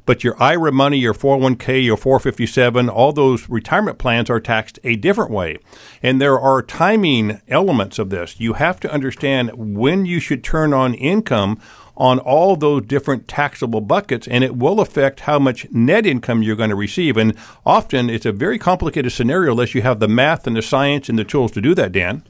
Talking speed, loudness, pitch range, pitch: 200 wpm, -16 LUFS, 115-140 Hz, 130 Hz